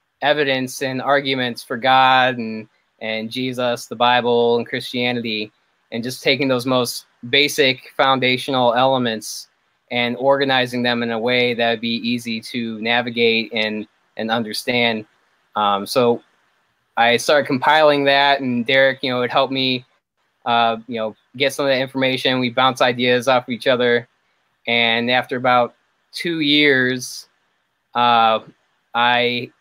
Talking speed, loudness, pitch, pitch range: 140 wpm, -18 LUFS, 125 Hz, 115-130 Hz